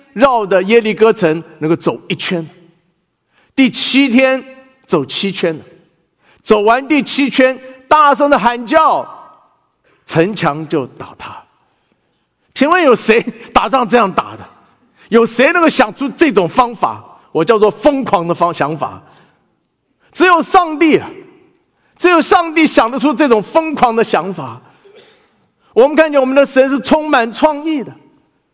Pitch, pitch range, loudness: 255 Hz, 200-300 Hz, -12 LUFS